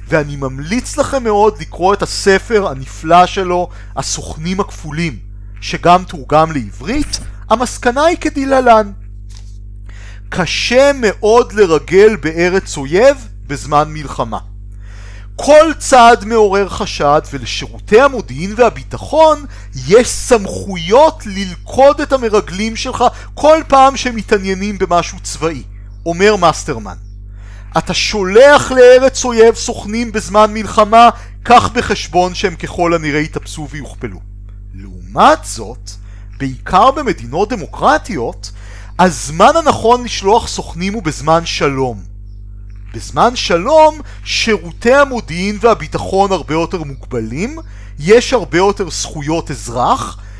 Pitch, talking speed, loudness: 175 Hz, 100 wpm, -12 LUFS